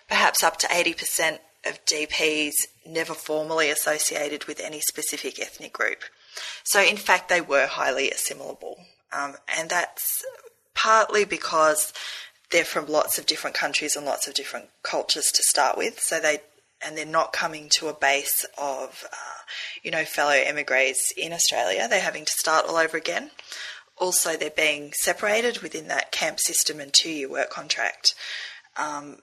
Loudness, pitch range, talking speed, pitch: -23 LUFS, 150-170 Hz, 160 wpm, 155 Hz